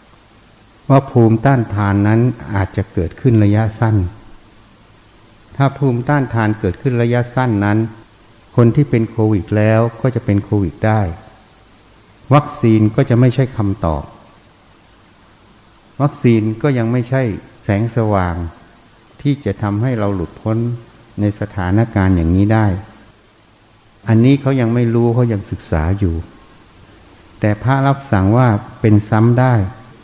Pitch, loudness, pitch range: 110 Hz, -15 LUFS, 100-120 Hz